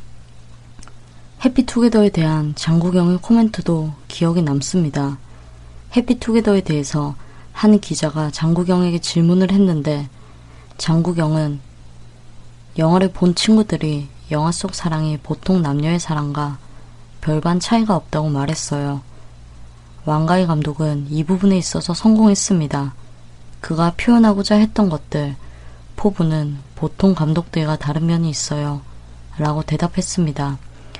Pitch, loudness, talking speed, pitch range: 155 Hz, -18 LUFS, 270 characters per minute, 140-180 Hz